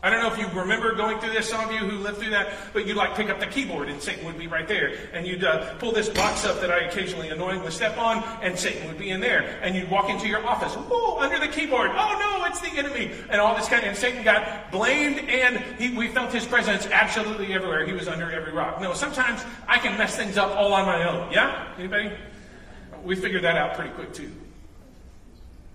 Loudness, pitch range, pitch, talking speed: -24 LUFS, 185-230 Hz, 205 Hz, 245 wpm